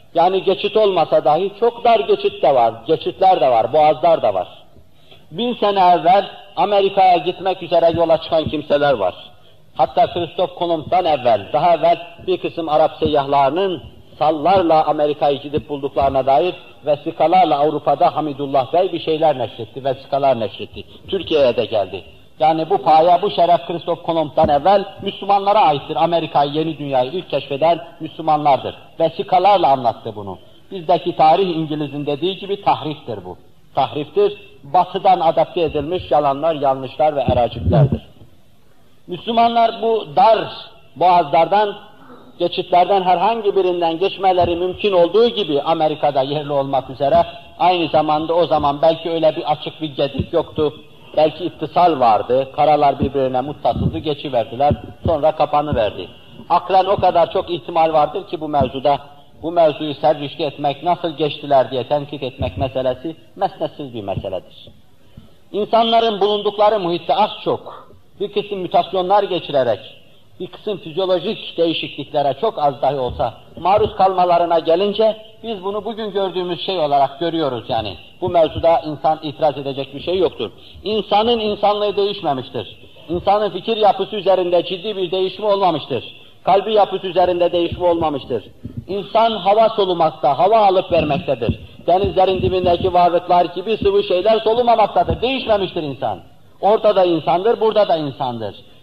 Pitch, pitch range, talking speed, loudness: 170 Hz, 150-195 Hz, 130 wpm, -17 LUFS